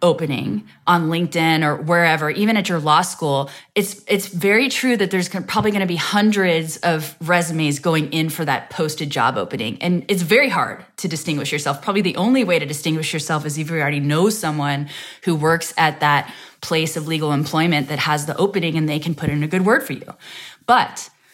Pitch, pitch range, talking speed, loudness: 165 Hz, 150-185 Hz, 205 wpm, -19 LUFS